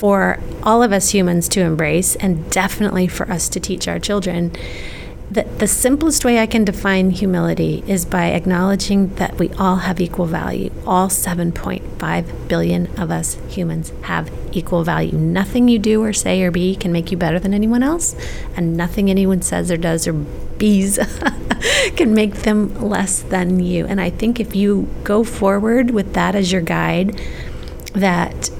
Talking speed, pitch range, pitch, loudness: 170 wpm, 175-205 Hz, 185 Hz, -17 LUFS